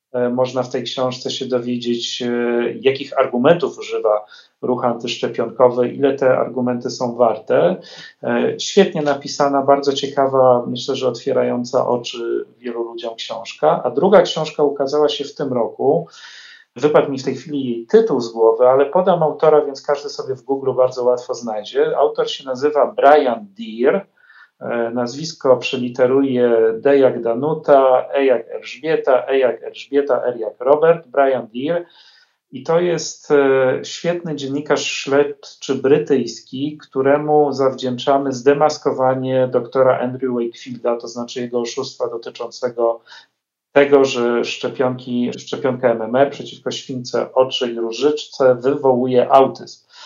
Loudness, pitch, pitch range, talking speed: -17 LUFS, 135 Hz, 125-150 Hz, 125 wpm